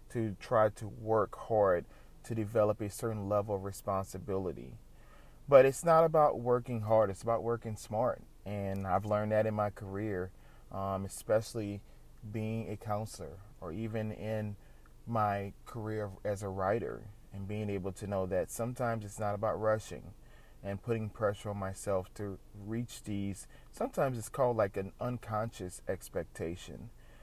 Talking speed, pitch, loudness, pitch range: 150 wpm, 105 Hz, -34 LUFS, 100-110 Hz